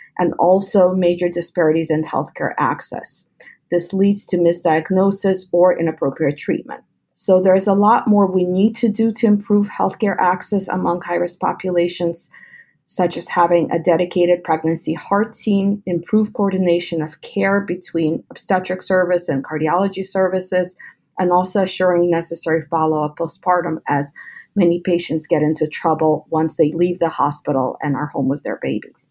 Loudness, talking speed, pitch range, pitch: -18 LUFS, 155 wpm, 165-190 Hz, 175 Hz